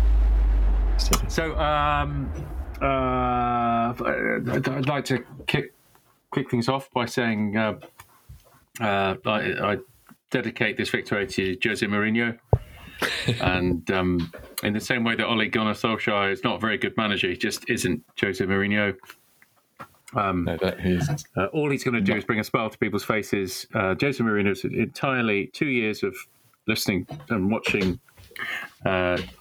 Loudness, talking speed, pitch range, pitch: -25 LUFS, 140 wpm, 95-125 Hz, 110 Hz